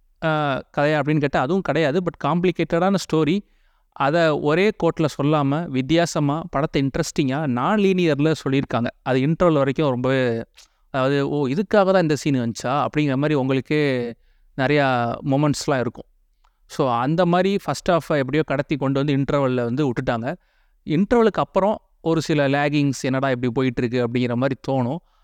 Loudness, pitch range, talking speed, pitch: -21 LUFS, 135-165 Hz, 140 wpm, 145 Hz